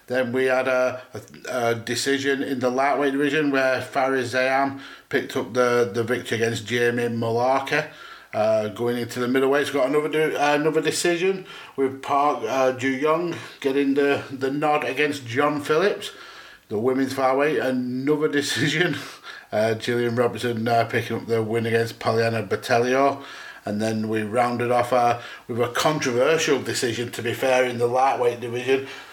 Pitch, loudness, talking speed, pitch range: 130 Hz, -23 LUFS, 165 wpm, 120-140 Hz